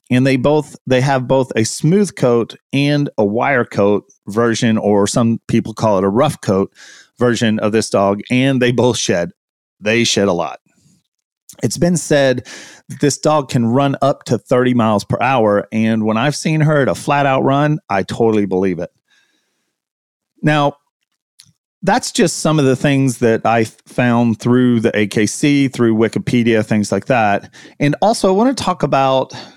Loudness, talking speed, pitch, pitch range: -15 LUFS, 175 wpm, 125 Hz, 110-145 Hz